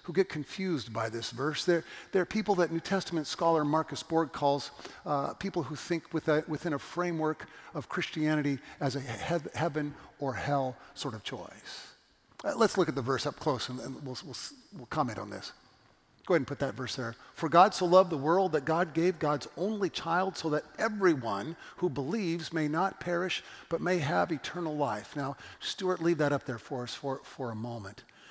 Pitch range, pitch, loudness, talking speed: 135-175 Hz, 155 Hz, -32 LUFS, 200 wpm